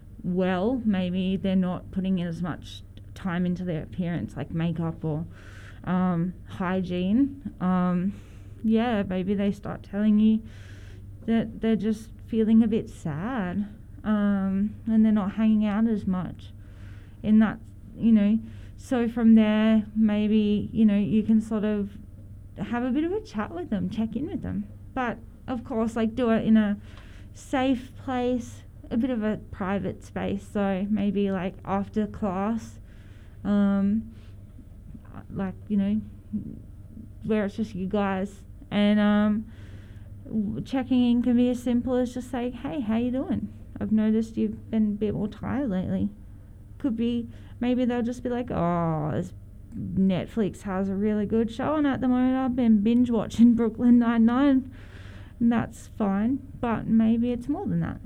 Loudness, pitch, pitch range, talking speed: -26 LUFS, 205 Hz, 150-225 Hz, 155 wpm